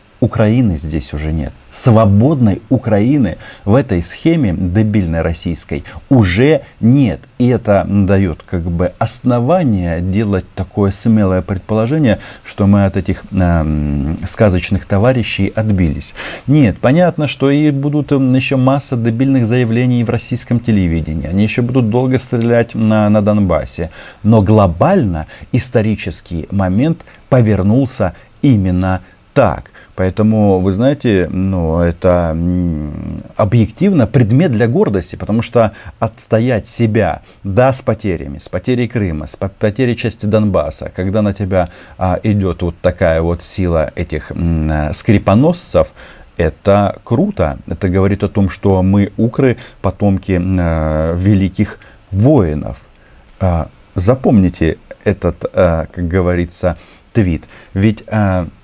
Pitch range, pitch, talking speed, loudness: 90-120 Hz, 100 Hz, 120 wpm, -14 LUFS